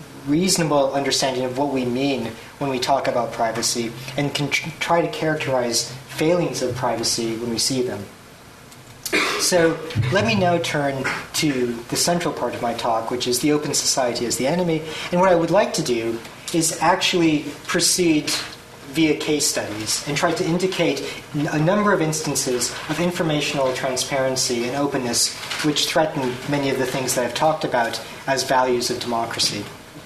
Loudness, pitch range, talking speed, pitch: -21 LUFS, 125-160 Hz, 170 wpm, 140 Hz